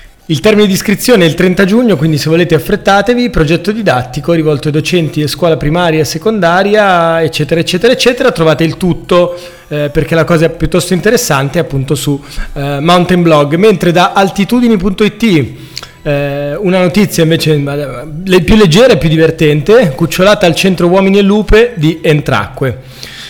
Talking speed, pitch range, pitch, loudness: 155 wpm, 155-195 Hz, 170 Hz, -9 LUFS